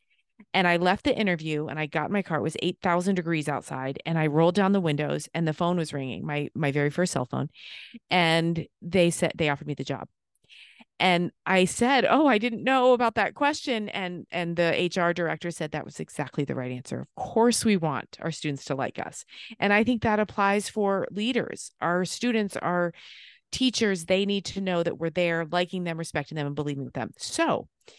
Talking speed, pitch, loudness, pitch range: 215 wpm, 175 Hz, -26 LUFS, 155-200 Hz